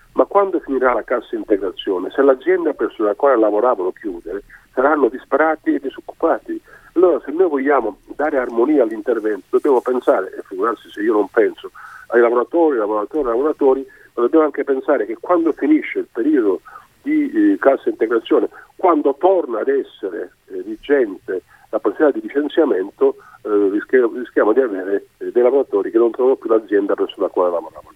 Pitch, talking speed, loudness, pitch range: 370 Hz, 165 wpm, -18 LUFS, 305-410 Hz